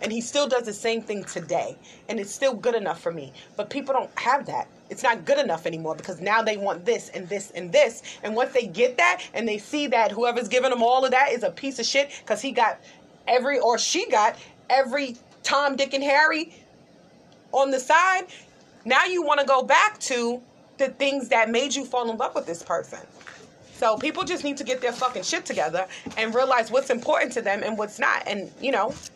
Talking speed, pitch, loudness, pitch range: 225 wpm, 255 Hz, -24 LUFS, 220-280 Hz